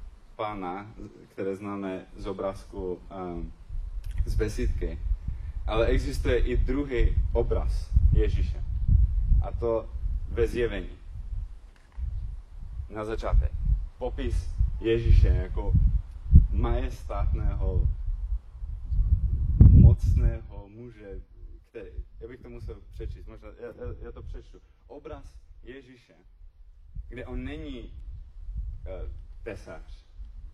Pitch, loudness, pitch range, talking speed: 85 Hz, -27 LUFS, 75-100 Hz, 85 wpm